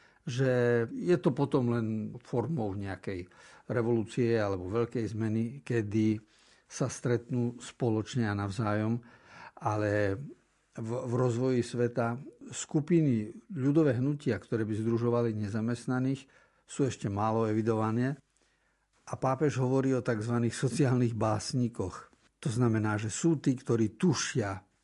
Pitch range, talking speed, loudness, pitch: 110-130 Hz, 115 wpm, -31 LUFS, 120 Hz